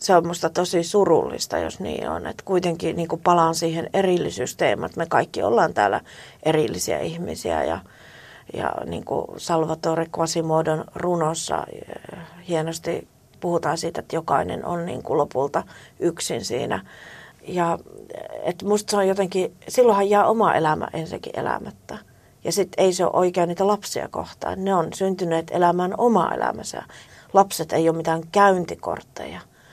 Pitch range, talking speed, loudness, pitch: 165-195 Hz, 145 wpm, -23 LUFS, 175 Hz